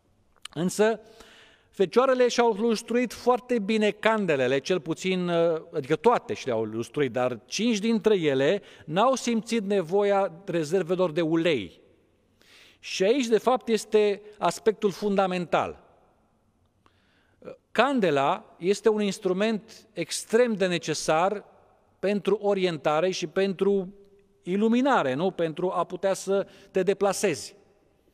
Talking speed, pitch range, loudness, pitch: 105 wpm, 175-220 Hz, -25 LUFS, 195 Hz